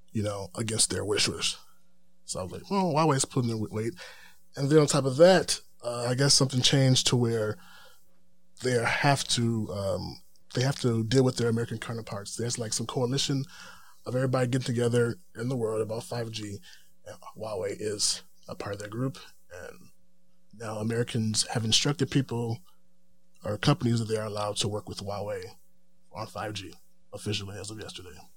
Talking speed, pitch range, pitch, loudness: 175 wpm, 110-140 Hz, 120 Hz, -28 LUFS